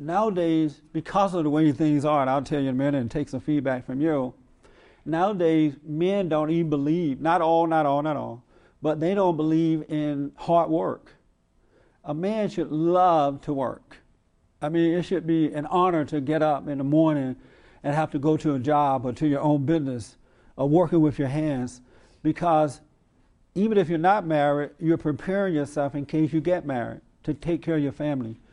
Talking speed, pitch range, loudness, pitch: 200 wpm, 140-165 Hz, -24 LUFS, 150 Hz